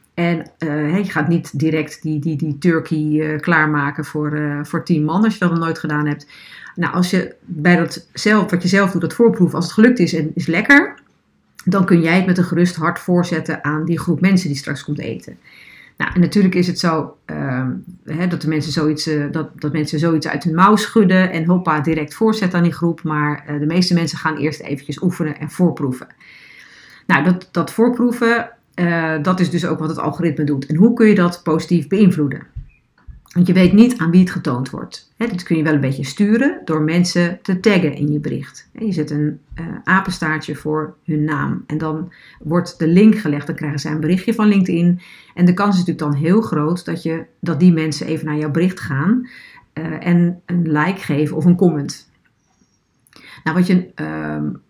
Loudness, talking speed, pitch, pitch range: -17 LUFS, 215 wpm, 165 Hz, 155-180 Hz